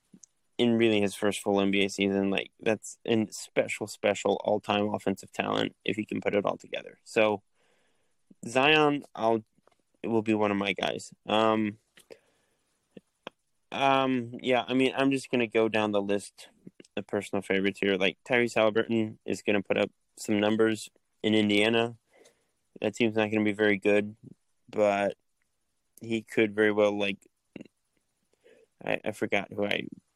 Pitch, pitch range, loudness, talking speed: 110 Hz, 100-115 Hz, -28 LUFS, 155 wpm